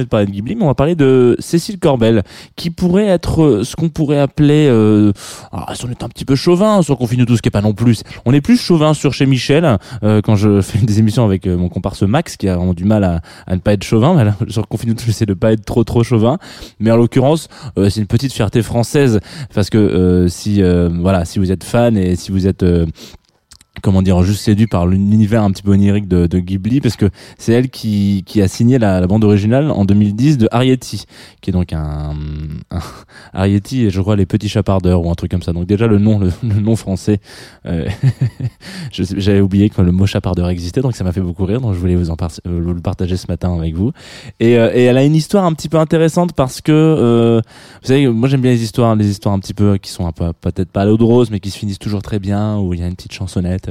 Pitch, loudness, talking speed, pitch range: 105 Hz, -14 LUFS, 260 wpm, 95-125 Hz